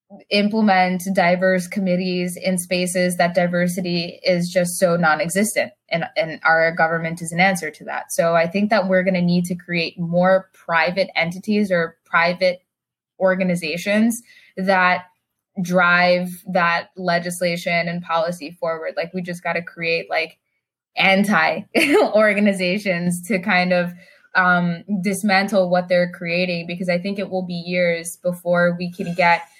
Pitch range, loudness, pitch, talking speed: 170-190 Hz, -19 LUFS, 180 Hz, 145 wpm